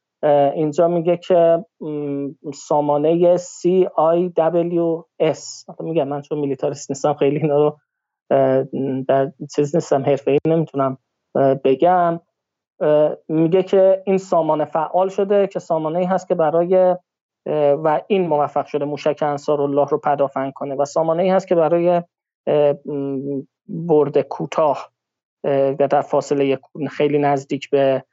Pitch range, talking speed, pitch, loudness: 140-170 Hz, 120 wpm, 150 Hz, -19 LUFS